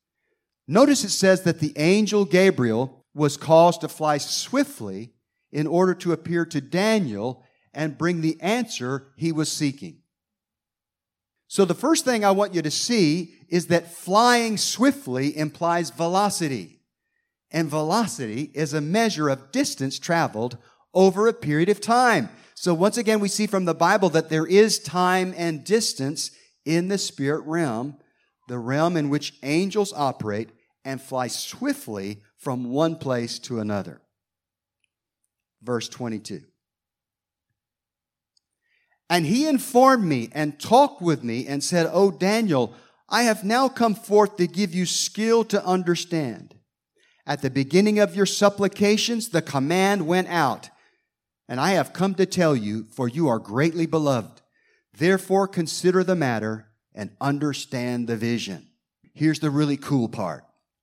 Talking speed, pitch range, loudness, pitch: 145 wpm, 135-195 Hz, -22 LUFS, 165 Hz